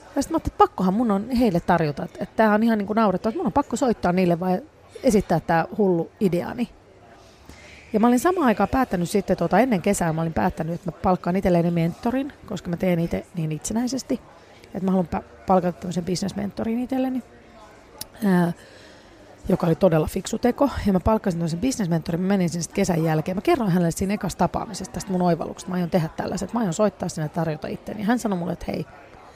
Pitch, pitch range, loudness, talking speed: 190 Hz, 175-220 Hz, -23 LUFS, 210 wpm